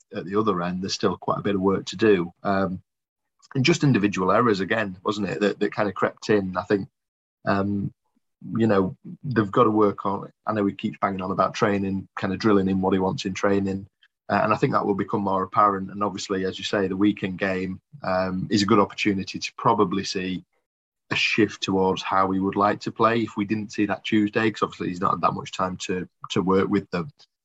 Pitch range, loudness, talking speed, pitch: 95-105 Hz, -24 LUFS, 235 wpm, 100 Hz